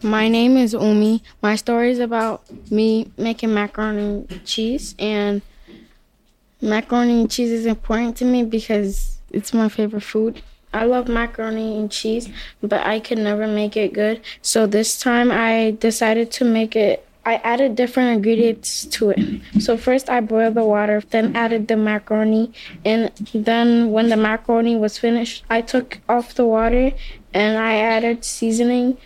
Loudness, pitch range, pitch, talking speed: -19 LUFS, 215-235 Hz, 225 Hz, 160 wpm